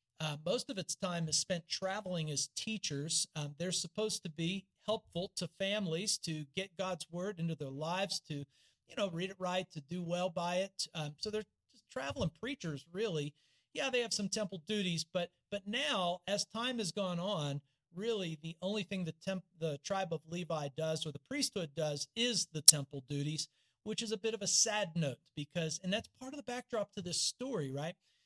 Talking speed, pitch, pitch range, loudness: 200 wpm, 180 Hz, 155-205 Hz, -36 LUFS